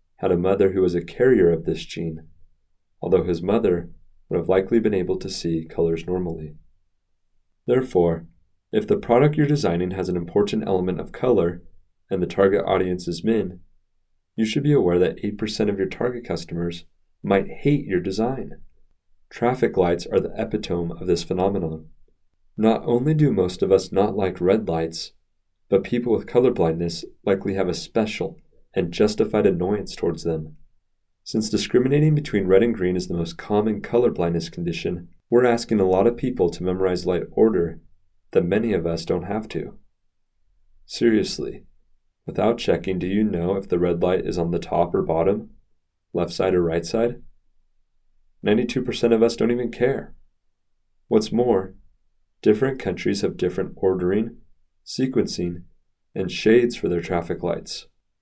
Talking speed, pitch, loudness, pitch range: 160 wpm, 90 Hz, -22 LUFS, 85-105 Hz